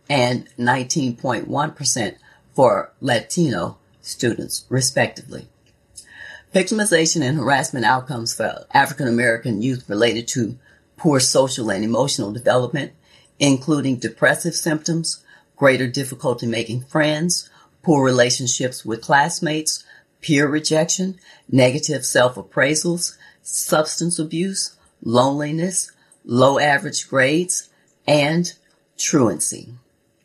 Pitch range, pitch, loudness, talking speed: 125-155 Hz, 140 Hz, -19 LUFS, 90 wpm